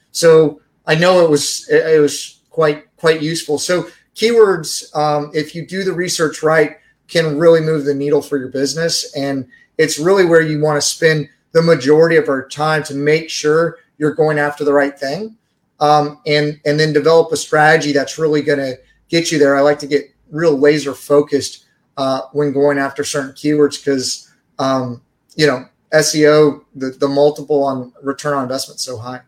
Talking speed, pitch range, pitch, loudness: 185 wpm, 140-160 Hz, 150 Hz, -15 LUFS